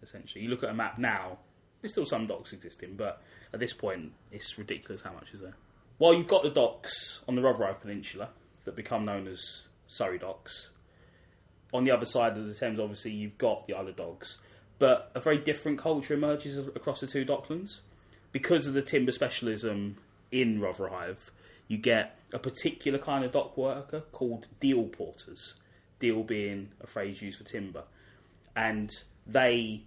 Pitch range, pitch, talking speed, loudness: 100-135 Hz, 110 Hz, 175 wpm, -31 LUFS